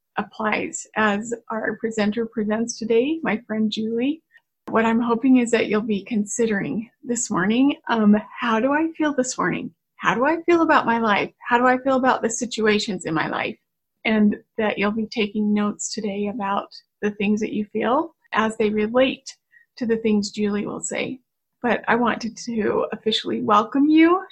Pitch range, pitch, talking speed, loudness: 215-255 Hz, 225 Hz, 180 wpm, -22 LUFS